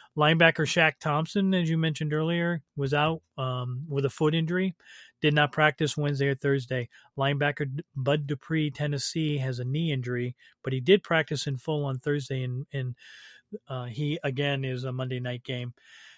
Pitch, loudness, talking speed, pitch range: 145 Hz, -28 LUFS, 165 wpm, 135-160 Hz